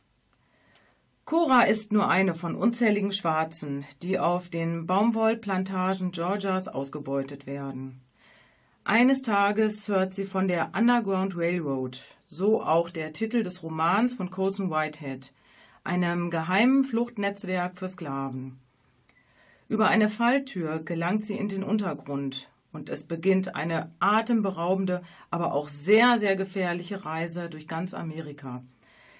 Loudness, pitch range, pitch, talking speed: -27 LUFS, 155-205 Hz, 180 Hz, 120 wpm